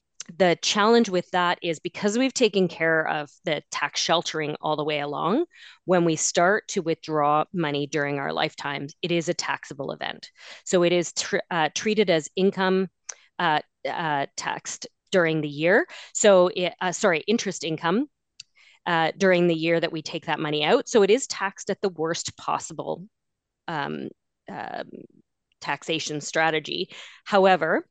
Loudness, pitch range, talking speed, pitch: -24 LUFS, 160-195 Hz, 160 wpm, 175 Hz